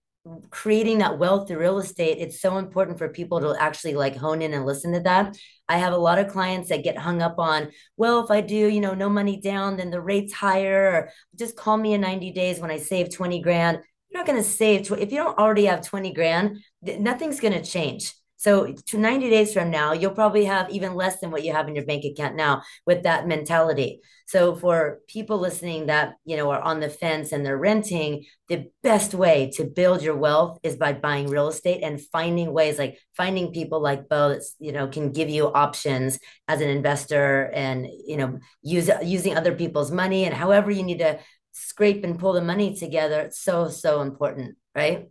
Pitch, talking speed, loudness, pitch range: 170 Hz, 220 wpm, -23 LUFS, 155-195 Hz